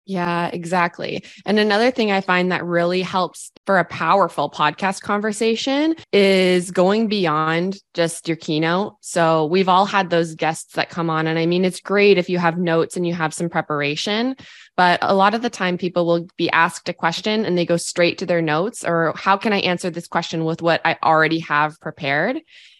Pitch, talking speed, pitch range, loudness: 175 Hz, 200 wpm, 165-195 Hz, -19 LUFS